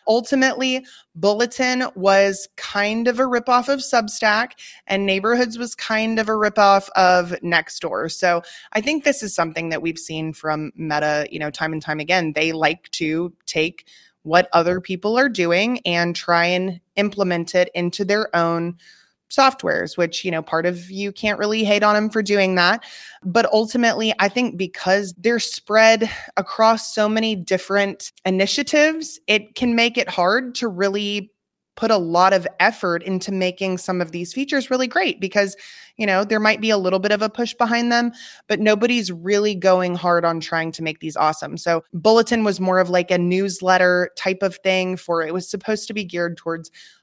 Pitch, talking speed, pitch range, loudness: 195 Hz, 180 wpm, 175-220 Hz, -19 LUFS